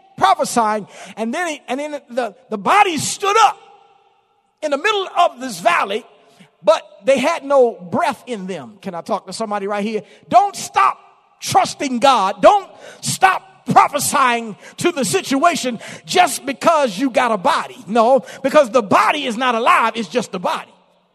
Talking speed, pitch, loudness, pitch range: 165 wpm, 270 Hz, -17 LUFS, 225-345 Hz